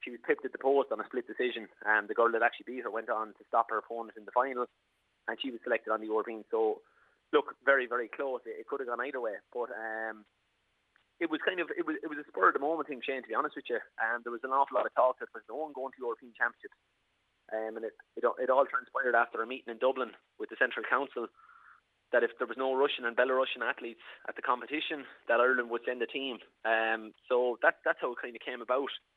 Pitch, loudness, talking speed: 135 Hz, -32 LUFS, 270 wpm